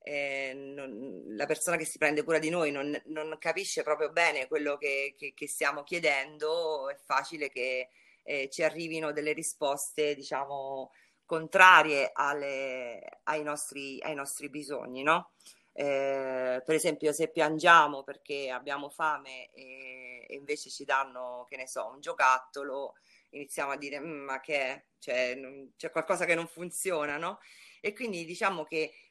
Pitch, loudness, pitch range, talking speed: 145 Hz, -30 LUFS, 135-160 Hz, 155 wpm